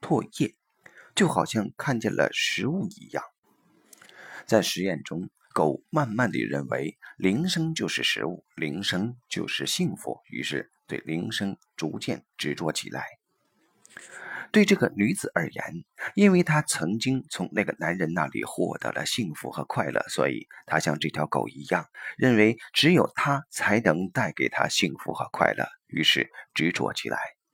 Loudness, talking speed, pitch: -26 LUFS, 220 characters per minute, 110 Hz